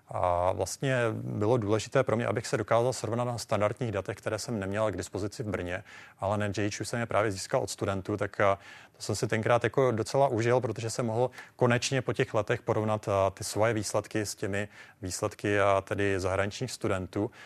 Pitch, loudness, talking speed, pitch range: 110 Hz, -30 LUFS, 180 wpm, 100-120 Hz